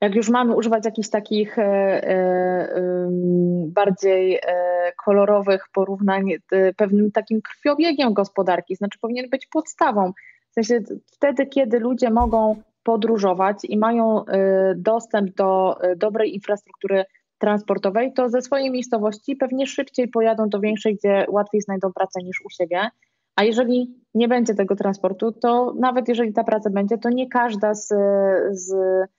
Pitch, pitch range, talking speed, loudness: 210 Hz, 195-235 Hz, 145 wpm, -20 LUFS